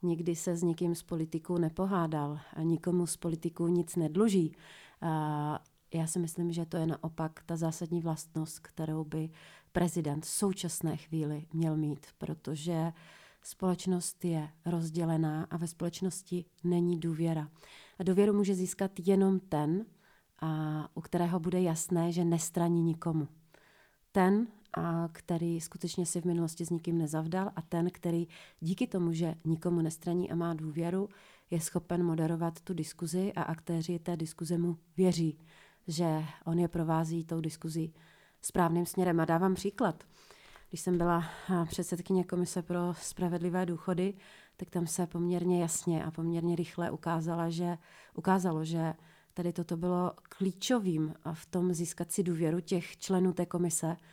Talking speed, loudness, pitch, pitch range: 145 wpm, -33 LUFS, 170 Hz, 165-180 Hz